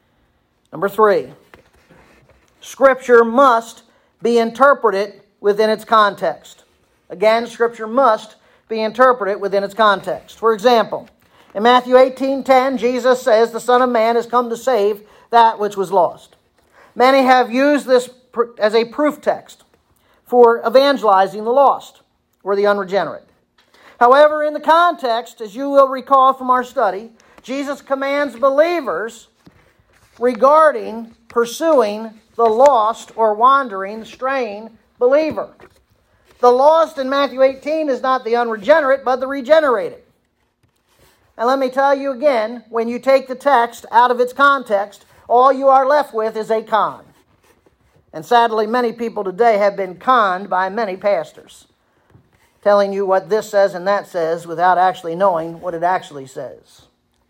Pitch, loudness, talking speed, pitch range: 235 Hz, -15 LUFS, 140 wpm, 215-270 Hz